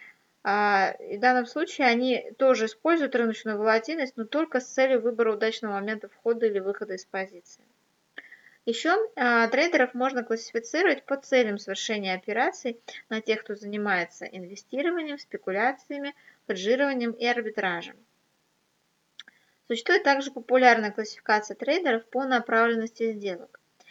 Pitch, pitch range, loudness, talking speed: 235 Hz, 215-270 Hz, -26 LUFS, 115 wpm